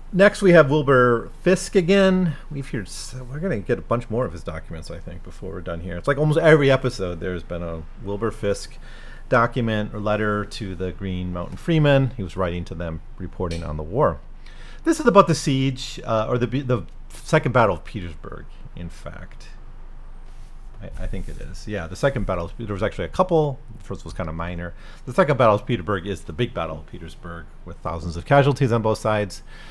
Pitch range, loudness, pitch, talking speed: 90-135 Hz, -21 LUFS, 105 Hz, 210 wpm